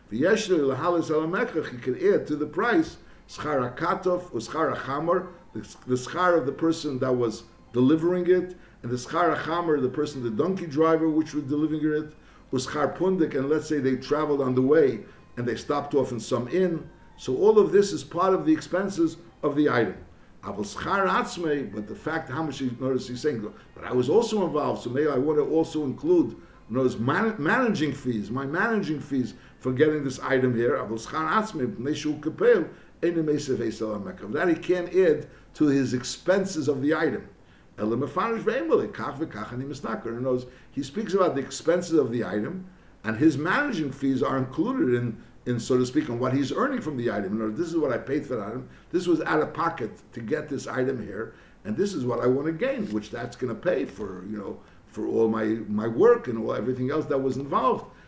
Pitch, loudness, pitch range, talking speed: 150 Hz, -26 LUFS, 125-170 Hz, 190 wpm